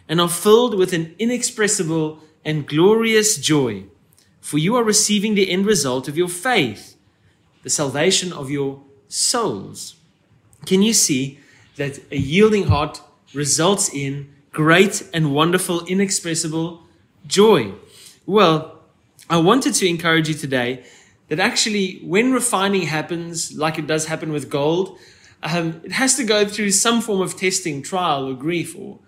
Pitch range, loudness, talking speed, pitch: 145-200 Hz, -18 LUFS, 145 wpm, 165 Hz